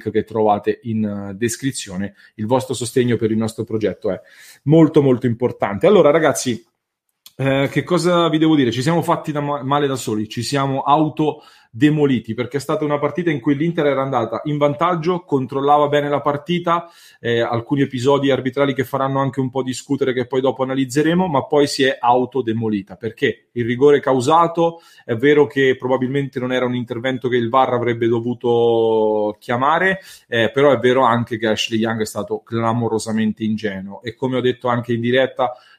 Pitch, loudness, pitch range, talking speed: 130 Hz, -18 LUFS, 115-145 Hz, 180 wpm